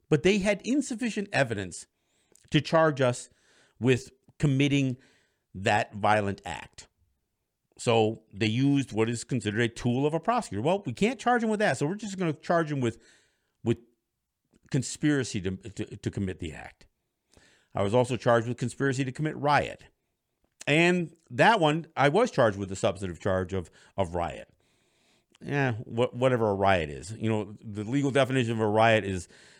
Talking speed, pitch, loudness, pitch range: 170 wpm, 125 Hz, -27 LUFS, 110-150 Hz